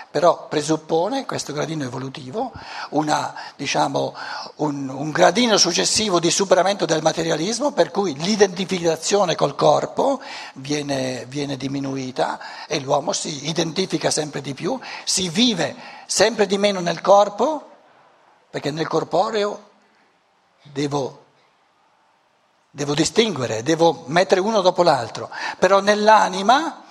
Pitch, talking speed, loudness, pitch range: 170 Hz, 110 wpm, -20 LUFS, 145-200 Hz